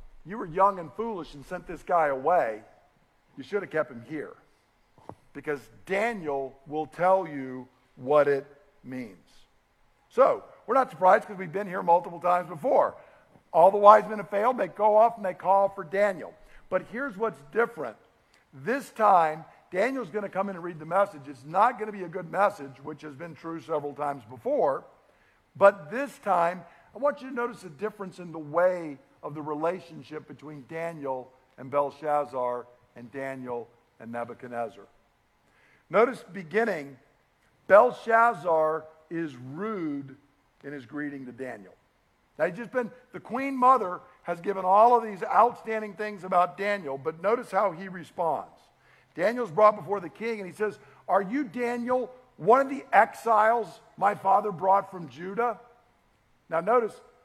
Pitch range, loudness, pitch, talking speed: 145-215 Hz, -26 LUFS, 180 Hz, 165 wpm